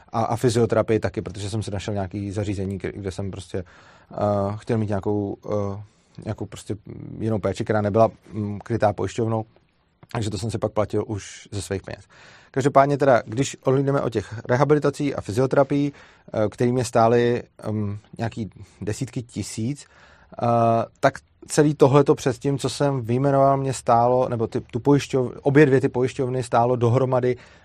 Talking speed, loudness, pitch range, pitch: 165 wpm, -22 LUFS, 105-130 Hz, 115 Hz